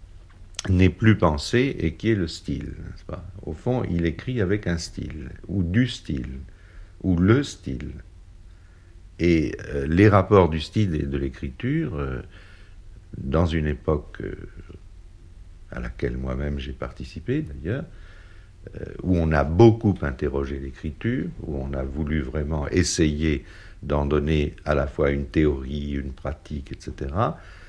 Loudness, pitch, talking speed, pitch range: -24 LUFS, 85 Hz, 145 wpm, 75-95 Hz